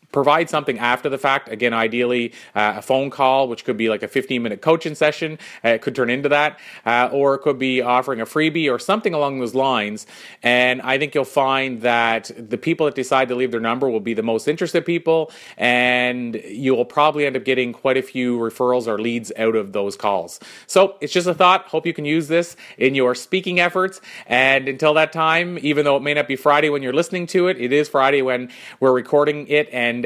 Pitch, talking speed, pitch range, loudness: 135 Hz, 225 wpm, 125-150 Hz, -19 LUFS